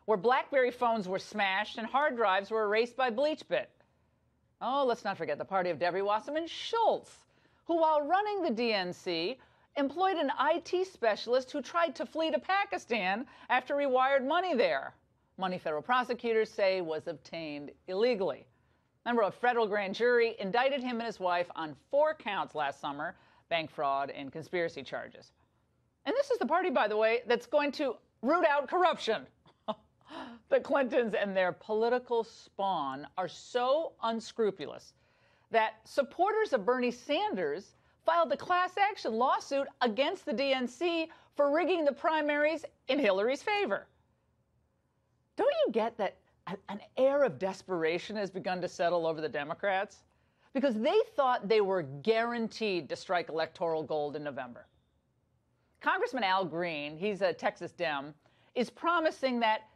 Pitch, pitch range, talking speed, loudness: 235 Hz, 190-290 Hz, 150 wpm, -31 LUFS